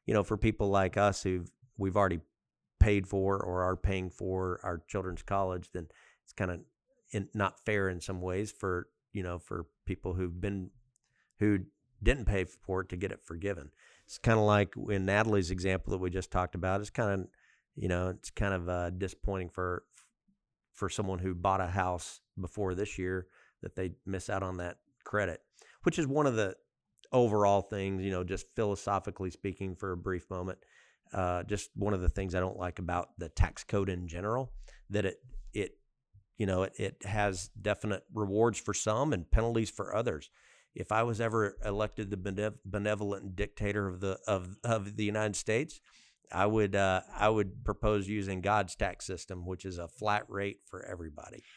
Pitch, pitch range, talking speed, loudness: 100 Hz, 90-105 Hz, 185 wpm, -34 LUFS